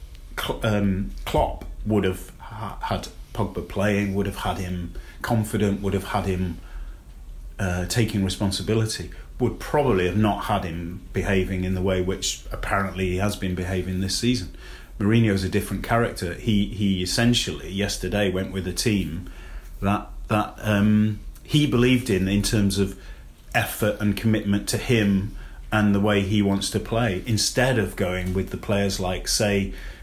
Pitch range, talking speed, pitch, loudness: 90-105 Hz, 160 wpm, 100 Hz, -24 LUFS